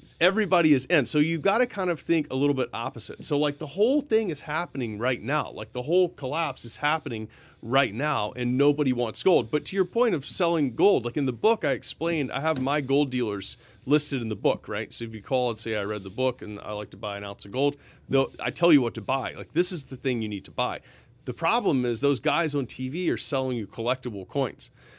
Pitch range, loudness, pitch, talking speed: 120-155 Hz, -26 LUFS, 135 Hz, 250 wpm